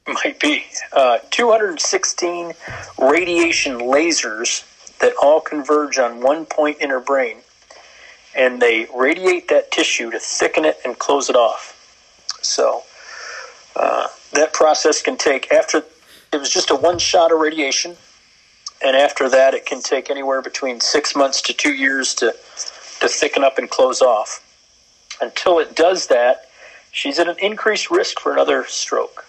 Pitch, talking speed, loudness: 160 Hz, 150 wpm, -17 LUFS